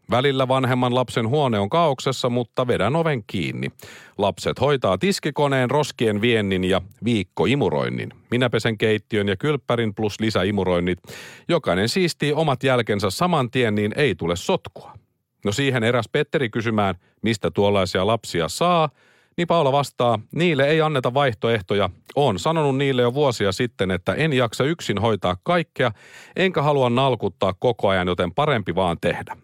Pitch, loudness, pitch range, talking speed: 120 Hz, -21 LUFS, 100-145 Hz, 145 wpm